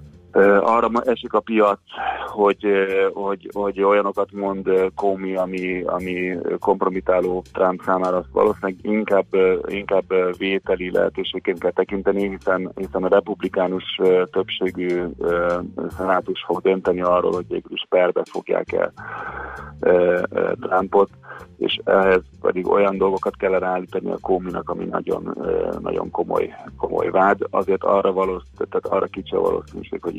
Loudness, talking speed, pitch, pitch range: -21 LUFS, 120 wpm, 95 Hz, 90-115 Hz